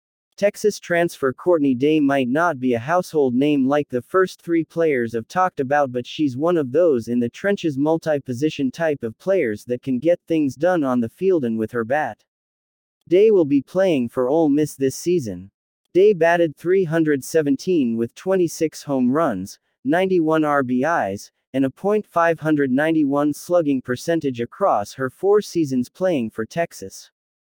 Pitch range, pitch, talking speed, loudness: 125-175 Hz, 150 Hz, 155 wpm, -20 LUFS